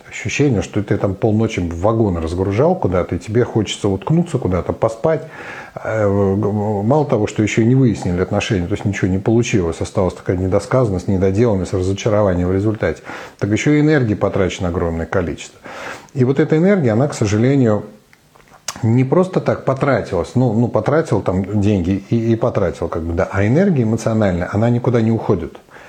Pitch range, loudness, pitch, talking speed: 95-120 Hz, -17 LUFS, 105 Hz, 165 wpm